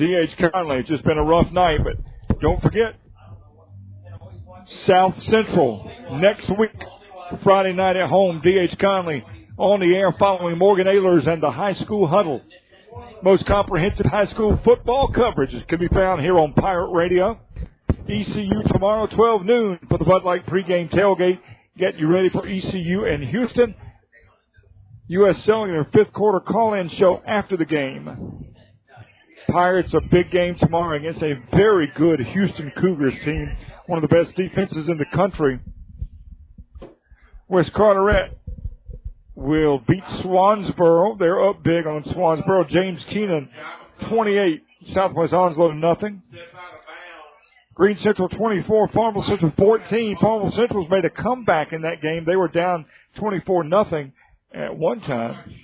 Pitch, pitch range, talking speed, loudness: 180 Hz, 155-195 Hz, 140 wpm, -19 LUFS